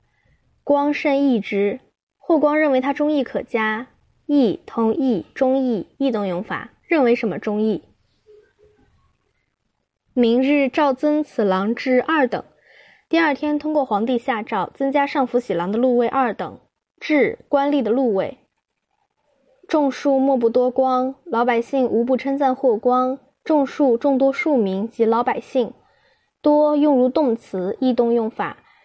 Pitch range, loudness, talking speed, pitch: 235-290 Hz, -20 LUFS, 205 characters per minute, 260 Hz